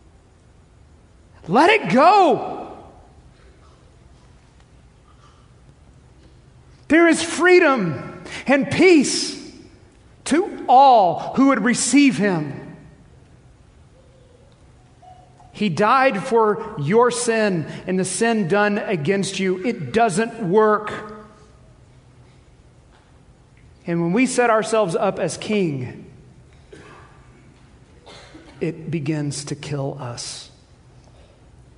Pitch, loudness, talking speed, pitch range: 210 Hz, -18 LUFS, 75 wpm, 155-245 Hz